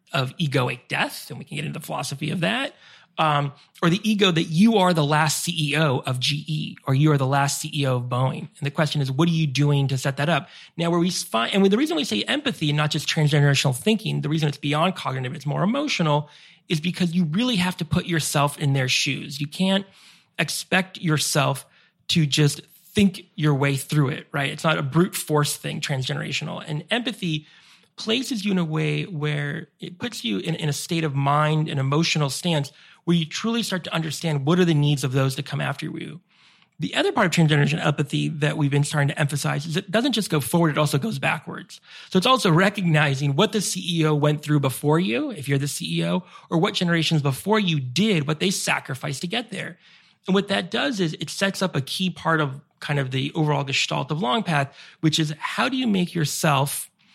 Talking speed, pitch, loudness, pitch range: 220 wpm, 155 Hz, -23 LUFS, 145-180 Hz